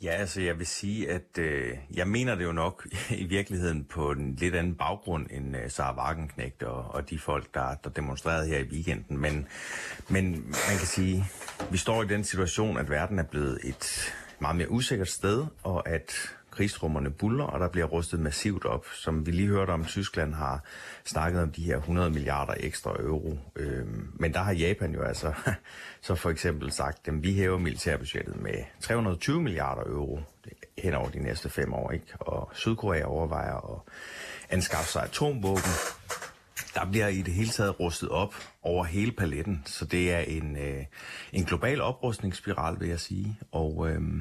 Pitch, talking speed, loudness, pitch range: 85 Hz, 180 wpm, -31 LUFS, 75-95 Hz